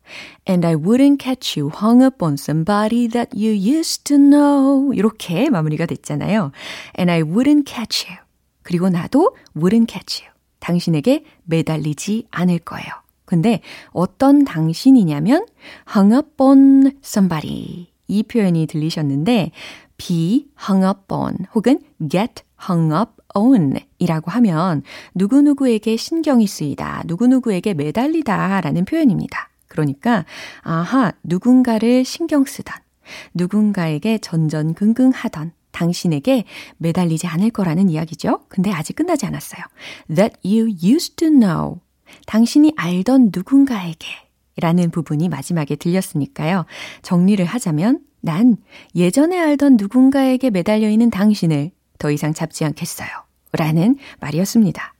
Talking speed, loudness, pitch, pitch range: 375 characters per minute, -17 LUFS, 205 Hz, 170-255 Hz